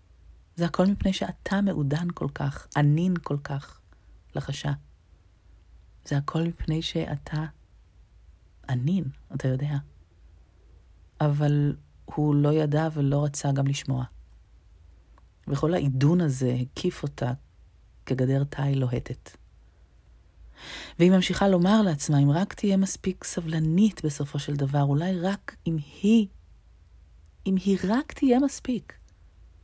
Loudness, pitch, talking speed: -26 LUFS, 145 Hz, 110 wpm